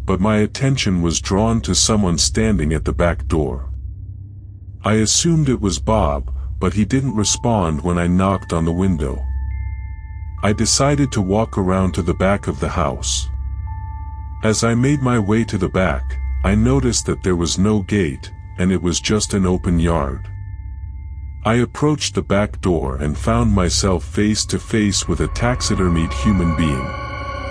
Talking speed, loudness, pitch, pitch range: 165 wpm, -18 LUFS, 95 Hz, 85-105 Hz